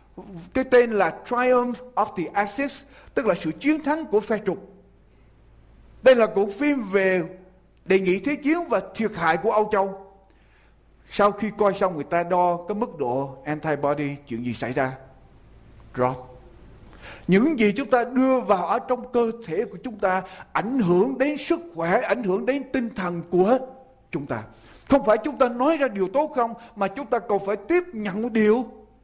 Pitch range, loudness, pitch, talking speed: 175-250 Hz, -23 LUFS, 205 Hz, 185 wpm